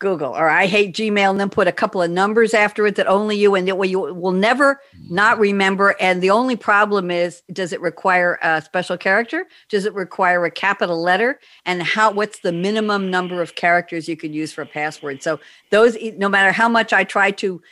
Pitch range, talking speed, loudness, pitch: 175-210 Hz, 220 wpm, -17 LUFS, 195 Hz